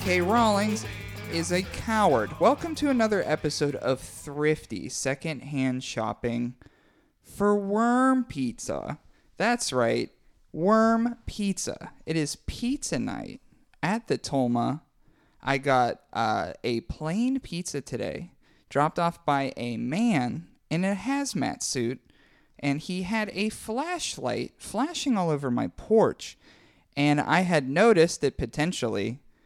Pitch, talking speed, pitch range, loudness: 160 Hz, 120 wpm, 135-220 Hz, -27 LUFS